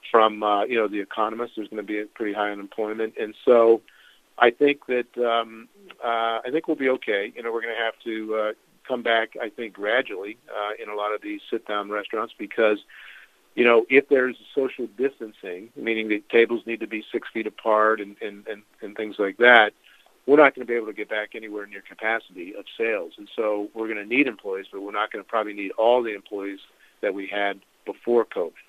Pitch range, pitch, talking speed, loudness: 105-120 Hz, 110 Hz, 220 wpm, -24 LUFS